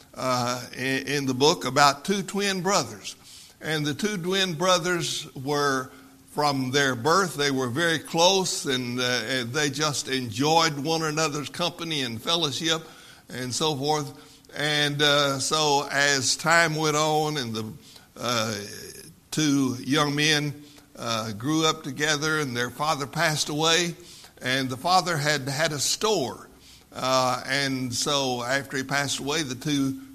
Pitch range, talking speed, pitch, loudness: 135-160 Hz, 145 wpm, 145 Hz, -24 LUFS